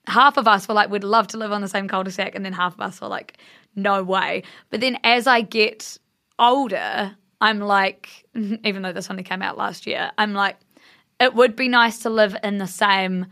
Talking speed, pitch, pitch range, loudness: 230 wpm, 210 Hz, 195-230 Hz, -20 LUFS